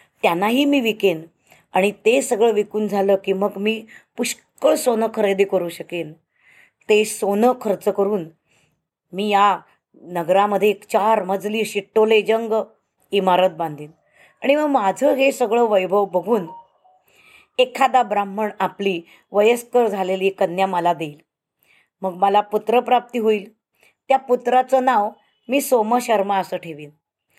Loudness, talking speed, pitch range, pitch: -19 LUFS, 125 wpm, 190-235 Hz, 205 Hz